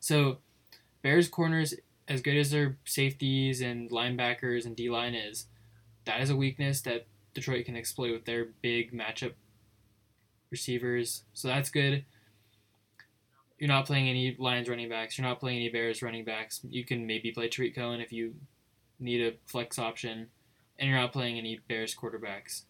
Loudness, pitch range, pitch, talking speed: -32 LUFS, 115-130 Hz, 120 Hz, 165 wpm